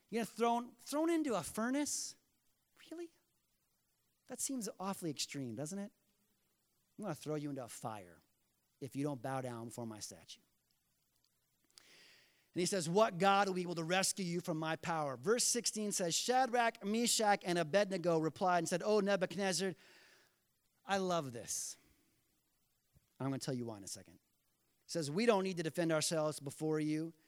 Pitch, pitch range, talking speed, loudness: 180 Hz, 150-210 Hz, 165 wpm, -37 LUFS